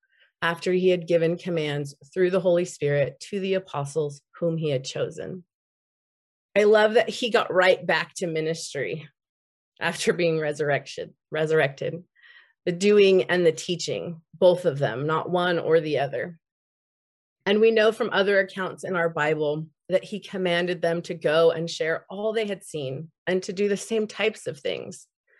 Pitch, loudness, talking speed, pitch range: 175 Hz, -24 LUFS, 170 wpm, 160-195 Hz